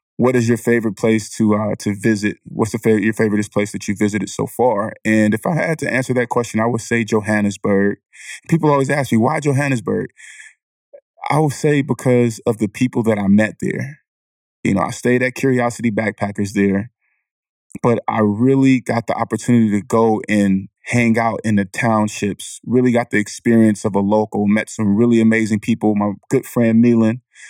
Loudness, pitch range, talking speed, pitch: -17 LUFS, 105-125 Hz, 190 wpm, 115 Hz